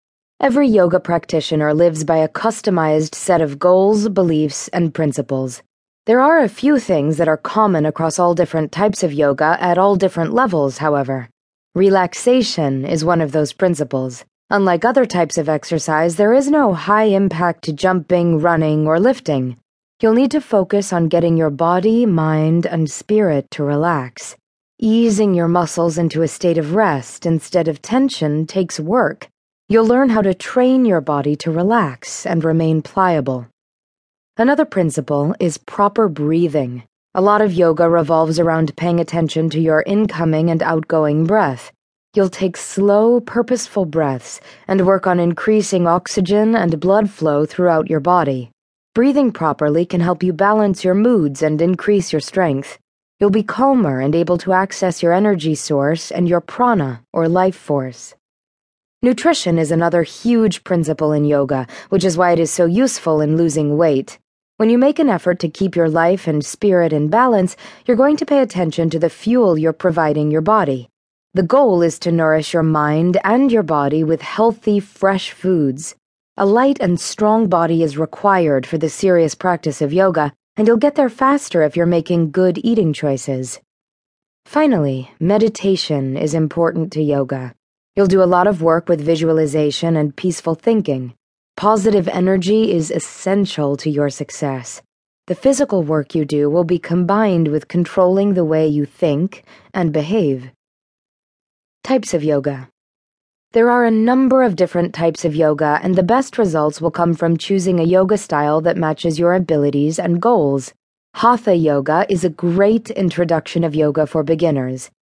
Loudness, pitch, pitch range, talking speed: -16 LUFS, 170 Hz, 155-200 Hz, 165 wpm